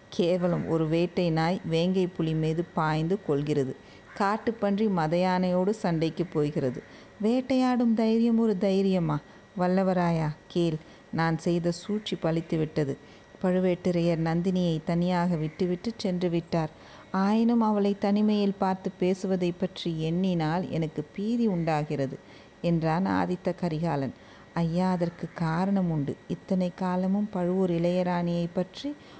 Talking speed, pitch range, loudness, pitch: 110 wpm, 165-190 Hz, -27 LUFS, 180 Hz